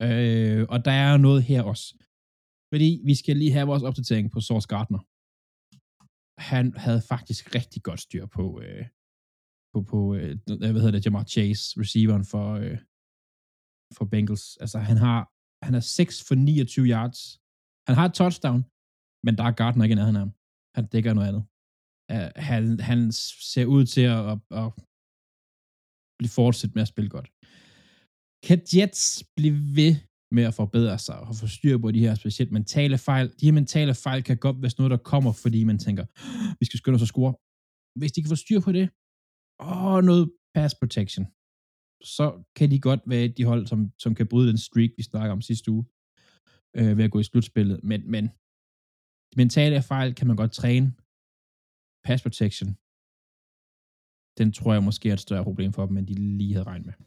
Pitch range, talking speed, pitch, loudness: 105-130 Hz, 185 wpm, 115 Hz, -24 LUFS